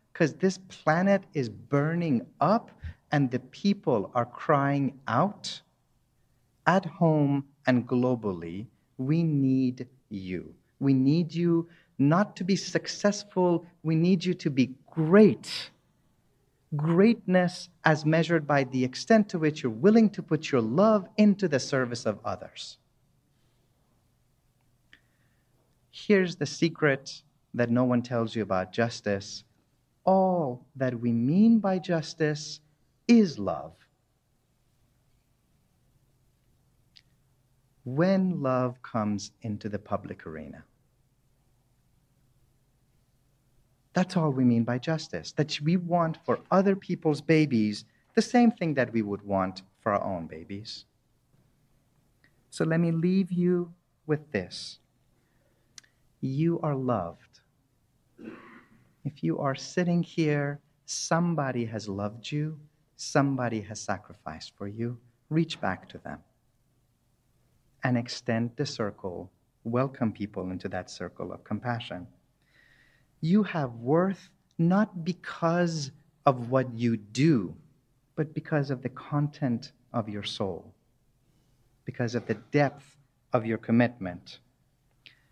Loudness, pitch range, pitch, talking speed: -27 LUFS, 120-160 Hz, 130 Hz, 115 wpm